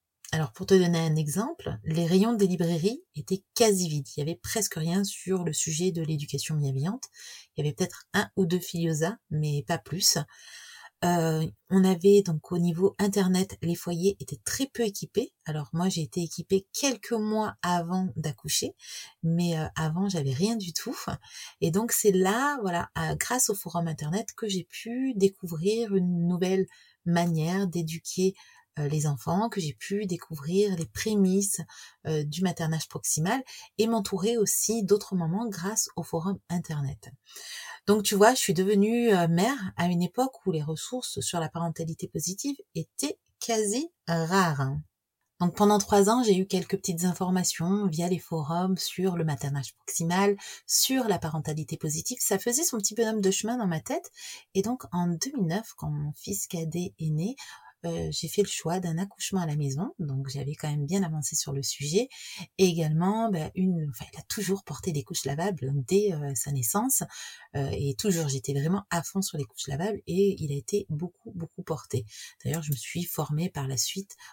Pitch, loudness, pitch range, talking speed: 180 Hz, -28 LUFS, 160-205 Hz, 180 wpm